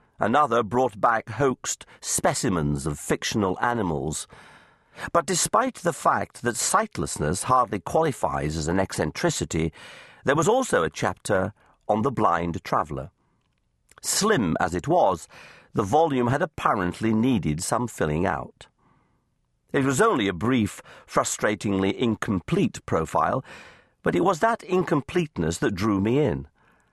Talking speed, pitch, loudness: 125 wpm, 110 Hz, -24 LUFS